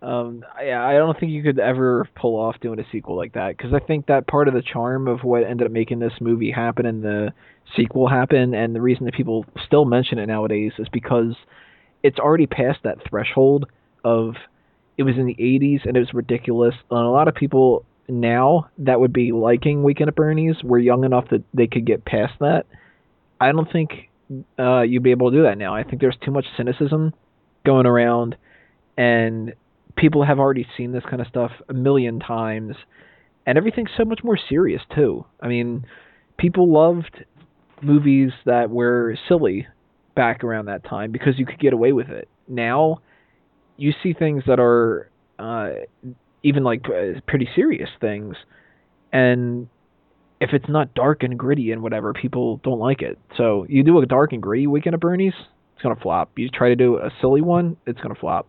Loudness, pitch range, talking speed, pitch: -19 LUFS, 120-145 Hz, 195 wpm, 125 Hz